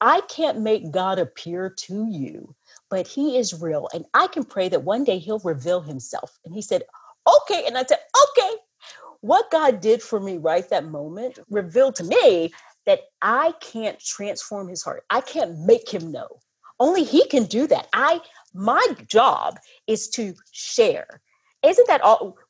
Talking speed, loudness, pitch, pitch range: 175 wpm, -21 LUFS, 225 Hz, 190-310 Hz